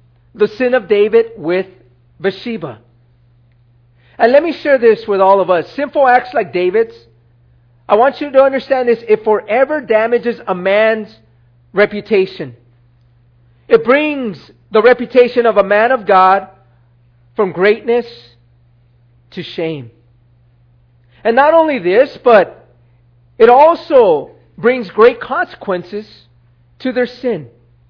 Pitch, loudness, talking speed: 195 Hz, -13 LUFS, 125 wpm